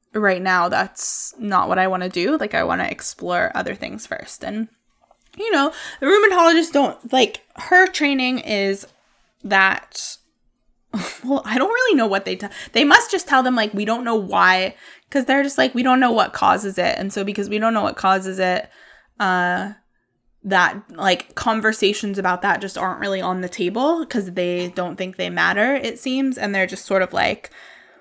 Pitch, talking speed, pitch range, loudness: 215 Hz, 195 wpm, 190-270 Hz, -19 LUFS